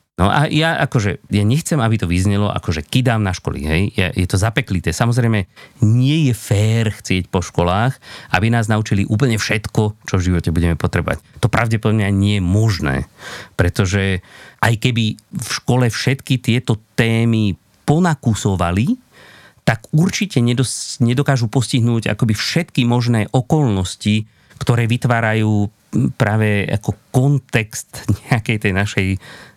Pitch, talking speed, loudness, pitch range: 110 Hz, 135 wpm, -17 LUFS, 100-130 Hz